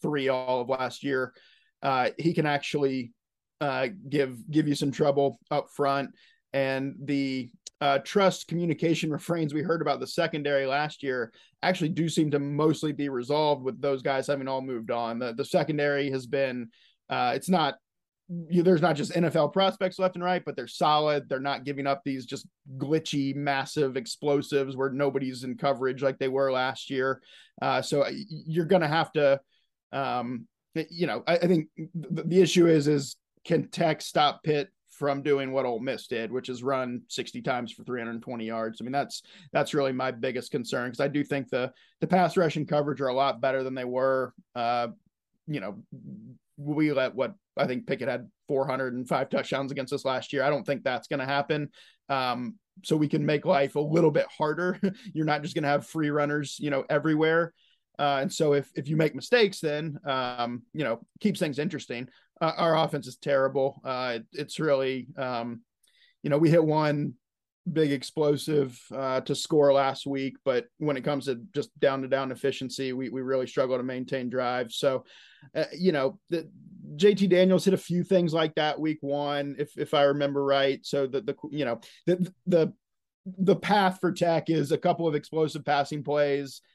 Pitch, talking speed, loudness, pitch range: 145 Hz, 195 wpm, -28 LUFS, 135-160 Hz